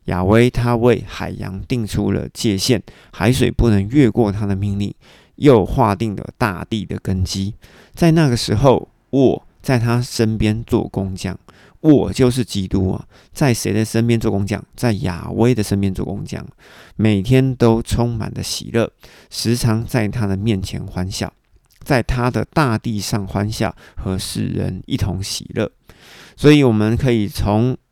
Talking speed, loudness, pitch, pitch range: 225 characters per minute, -18 LUFS, 110 Hz, 100-120 Hz